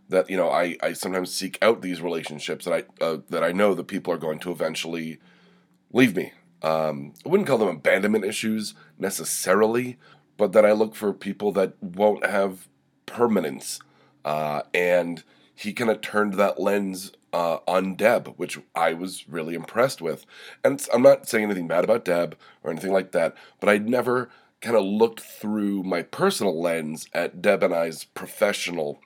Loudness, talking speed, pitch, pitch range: -24 LUFS, 180 wpm, 95 Hz, 85-105 Hz